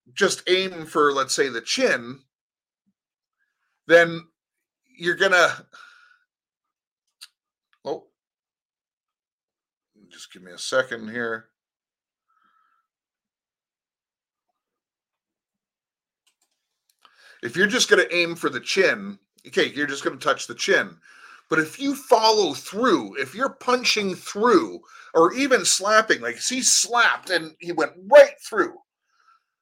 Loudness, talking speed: -21 LUFS, 105 wpm